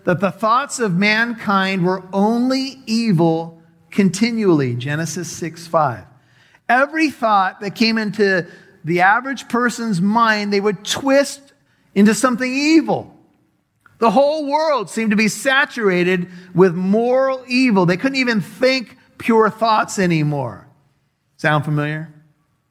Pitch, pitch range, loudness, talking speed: 205 Hz, 175-240 Hz, -17 LUFS, 120 wpm